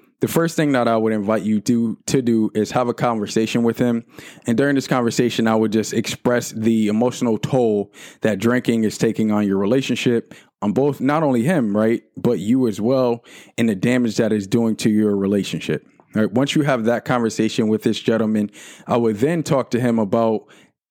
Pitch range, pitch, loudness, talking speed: 110-125 Hz, 115 Hz, -19 LUFS, 205 wpm